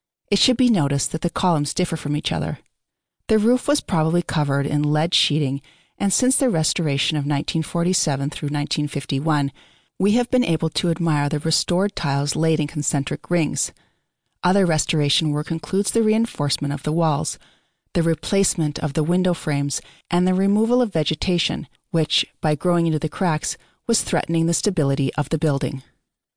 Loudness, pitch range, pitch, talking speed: -21 LUFS, 150-180 Hz, 160 Hz, 165 wpm